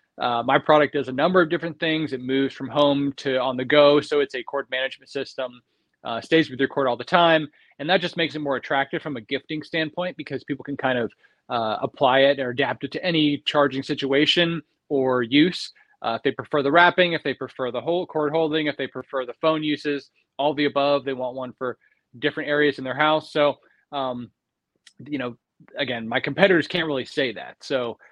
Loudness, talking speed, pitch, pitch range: -23 LUFS, 220 wpm, 145 Hz, 130-155 Hz